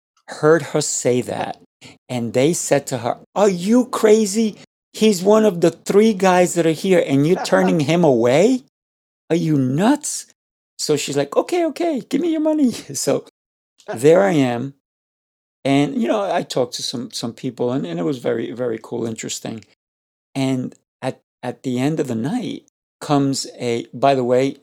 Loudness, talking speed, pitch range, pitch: -19 LUFS, 175 wpm, 130-215 Hz, 155 Hz